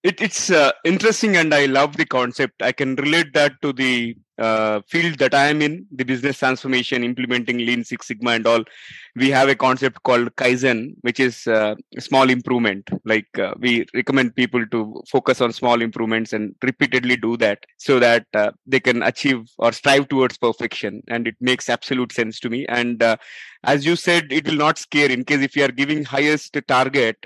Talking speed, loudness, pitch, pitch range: 200 wpm, -19 LUFS, 130 Hz, 120-140 Hz